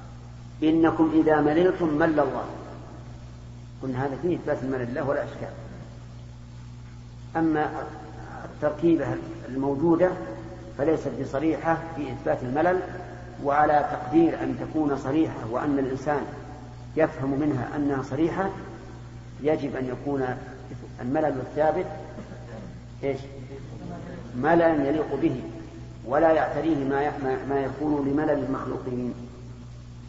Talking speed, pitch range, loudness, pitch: 95 wpm, 120-150 Hz, -26 LUFS, 135 Hz